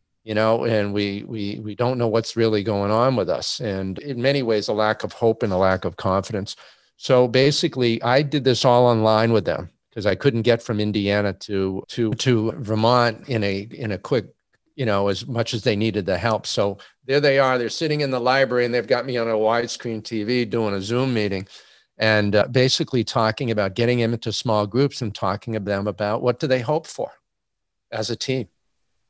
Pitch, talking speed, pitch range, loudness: 115 Hz, 215 wpm, 105-125 Hz, -21 LUFS